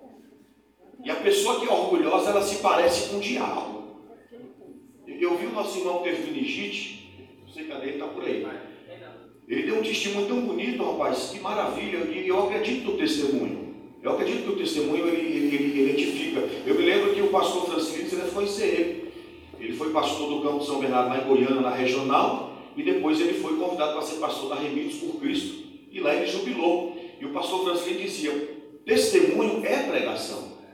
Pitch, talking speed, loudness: 205 Hz, 185 wpm, -26 LUFS